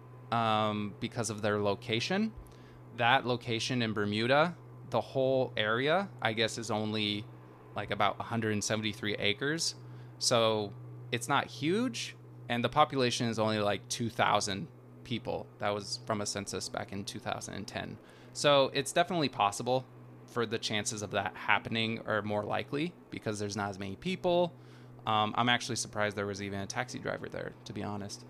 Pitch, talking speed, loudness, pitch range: 110 Hz, 155 wpm, -32 LUFS, 100-125 Hz